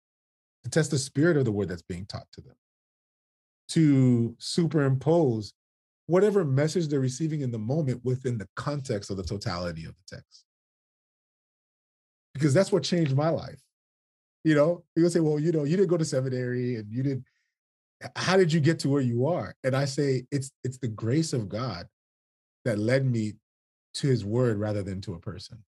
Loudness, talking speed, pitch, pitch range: -27 LUFS, 185 wpm, 130 Hz, 110-155 Hz